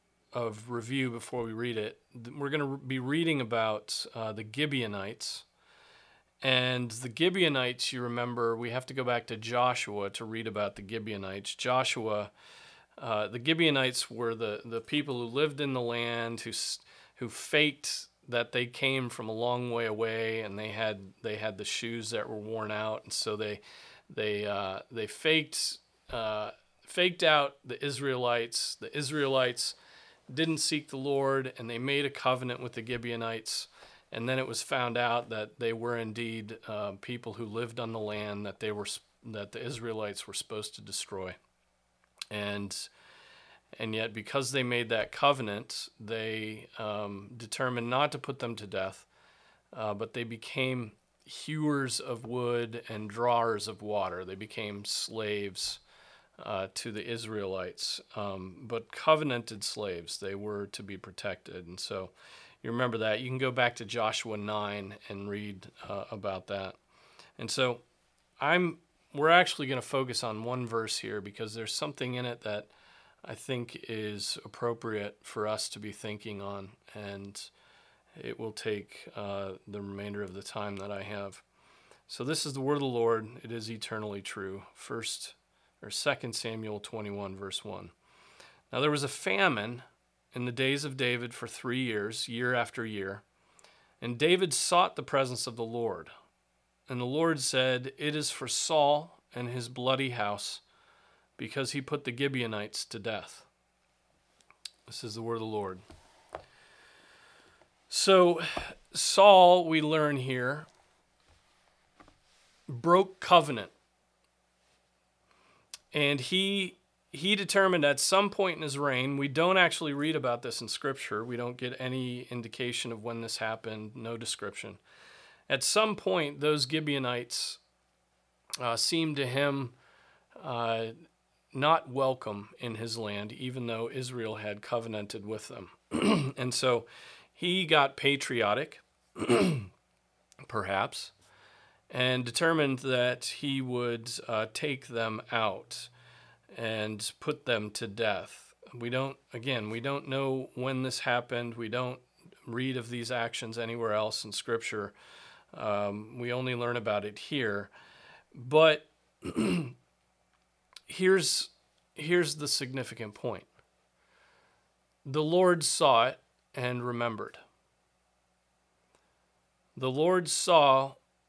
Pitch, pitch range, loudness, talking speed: 120 Hz, 105-130 Hz, -31 LUFS, 145 wpm